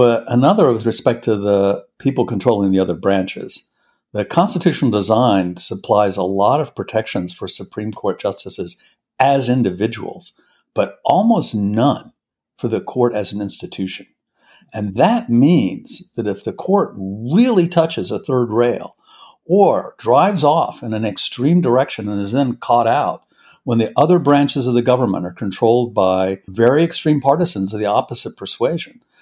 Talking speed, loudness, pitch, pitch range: 155 wpm, -17 LUFS, 120 Hz, 100-140 Hz